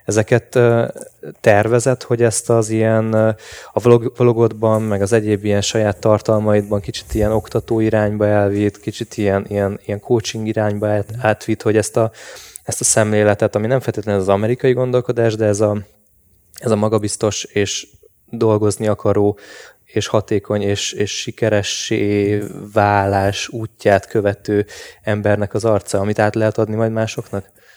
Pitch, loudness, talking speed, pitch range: 110 Hz, -17 LUFS, 140 wpm, 105-115 Hz